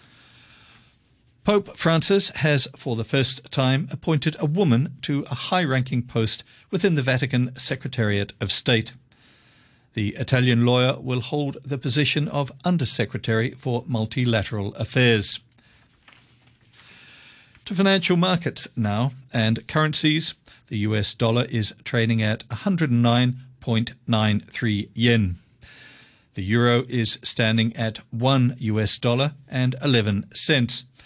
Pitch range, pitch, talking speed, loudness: 115-140 Hz, 125 Hz, 110 wpm, -22 LUFS